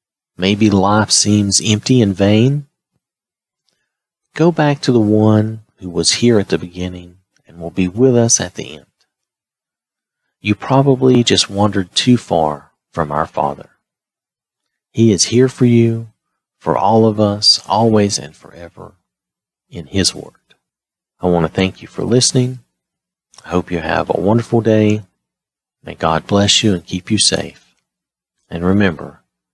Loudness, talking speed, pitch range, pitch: -14 LUFS, 150 wpm, 90-115 Hz, 105 Hz